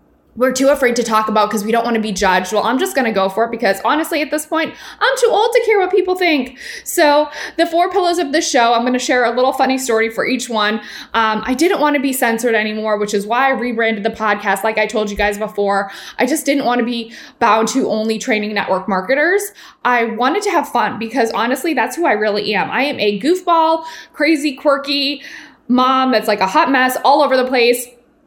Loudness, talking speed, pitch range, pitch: -15 LUFS, 240 wpm, 220-295 Hz, 250 Hz